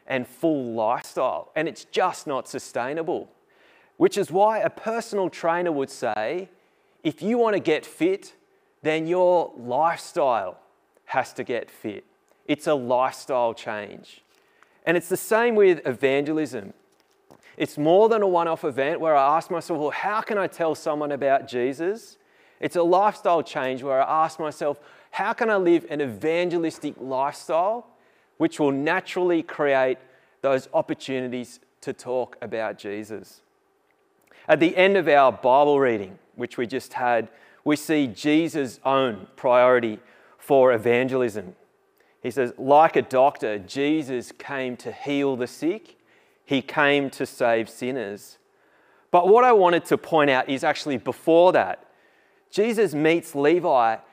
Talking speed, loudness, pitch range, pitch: 145 wpm, -23 LUFS, 130-180 Hz, 150 Hz